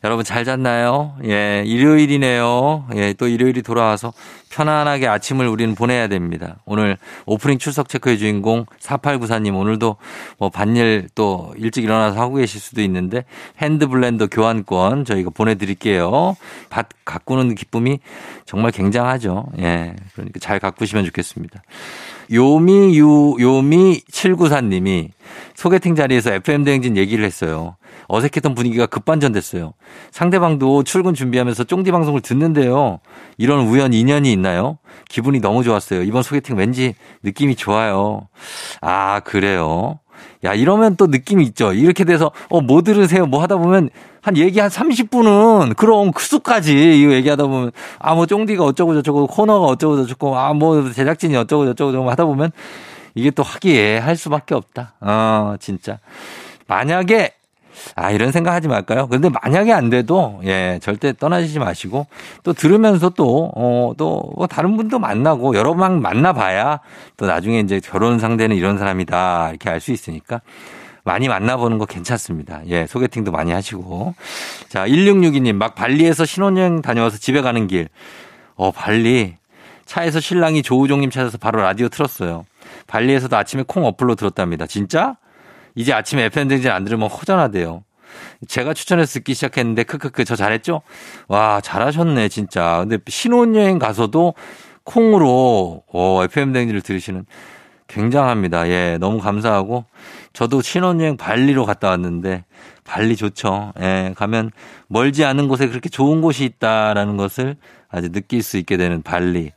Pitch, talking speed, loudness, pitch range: 120 Hz, 335 characters per minute, -16 LUFS, 105-150 Hz